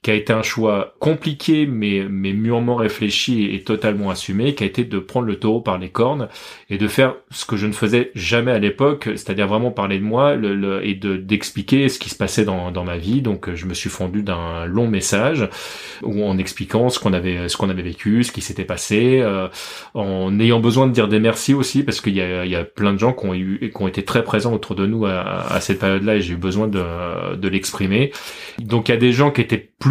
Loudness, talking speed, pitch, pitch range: -19 LUFS, 250 wpm, 105 Hz, 95-115 Hz